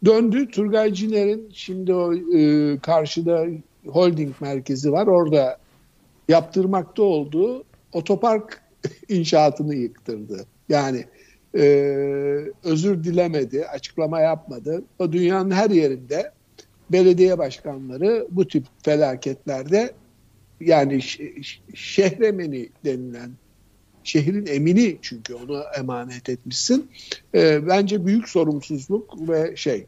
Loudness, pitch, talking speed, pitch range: -21 LUFS, 160 Hz, 95 wpm, 135-190 Hz